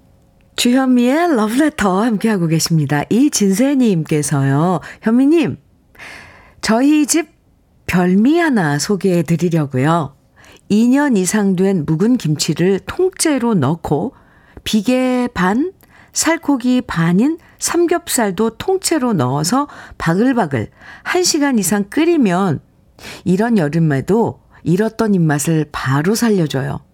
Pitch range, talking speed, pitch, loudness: 165-260 Hz, 225 characters per minute, 210 Hz, -15 LUFS